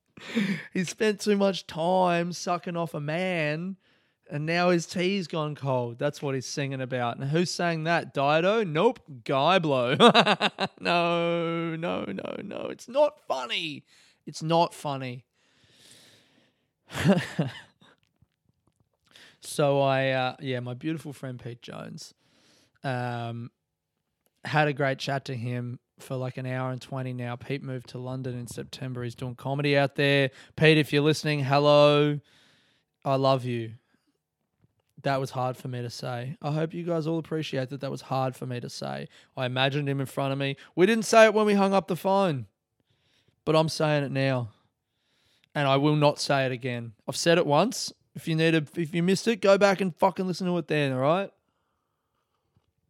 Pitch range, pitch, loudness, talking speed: 130-170 Hz, 145 Hz, -26 LUFS, 170 wpm